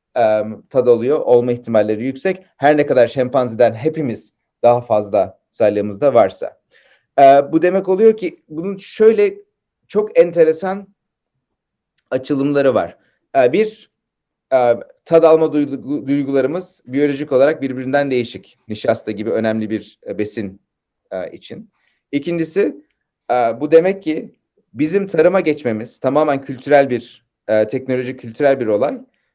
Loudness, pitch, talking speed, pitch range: -16 LUFS, 140 Hz, 105 wpm, 120-175 Hz